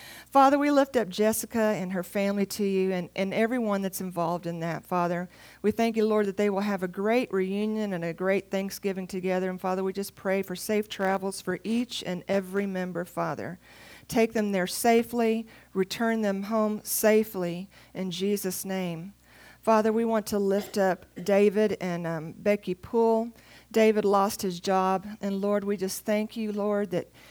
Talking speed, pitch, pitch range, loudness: 180 wpm, 200 Hz, 185-215 Hz, -27 LUFS